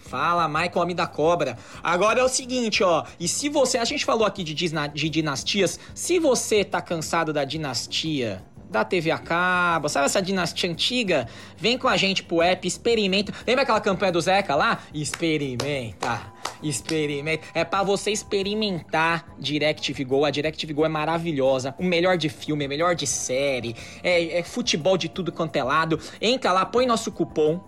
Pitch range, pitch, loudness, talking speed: 150-195 Hz, 170 Hz, -23 LUFS, 180 wpm